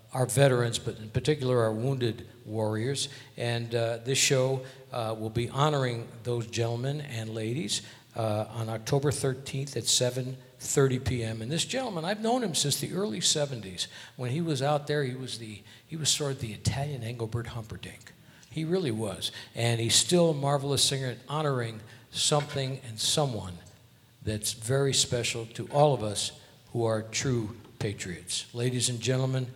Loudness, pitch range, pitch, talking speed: -29 LUFS, 115-140 Hz, 125 Hz, 165 wpm